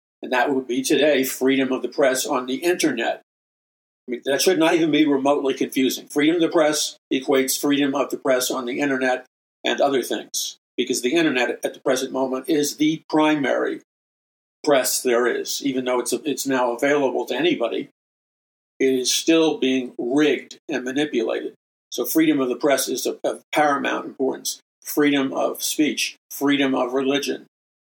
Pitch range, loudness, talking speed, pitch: 130-150 Hz, -21 LUFS, 175 wpm, 140 Hz